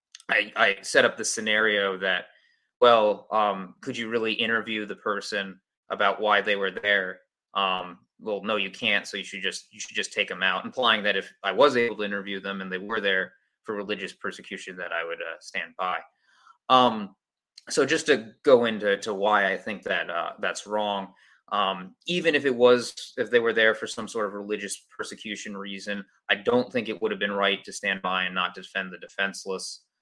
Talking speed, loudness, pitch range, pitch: 205 wpm, -25 LUFS, 100-115 Hz, 105 Hz